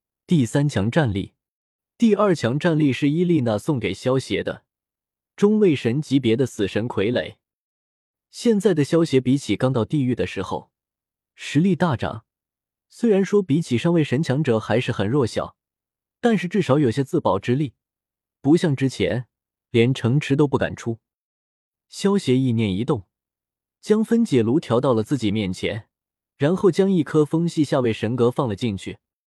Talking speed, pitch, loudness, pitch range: 235 characters per minute, 135 Hz, -21 LUFS, 115-170 Hz